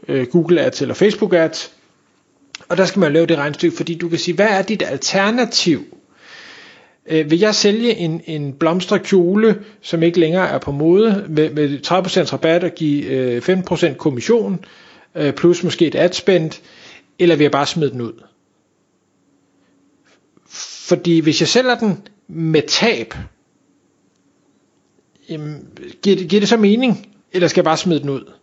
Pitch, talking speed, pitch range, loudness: 175 Hz, 160 wpm, 160-200 Hz, -16 LUFS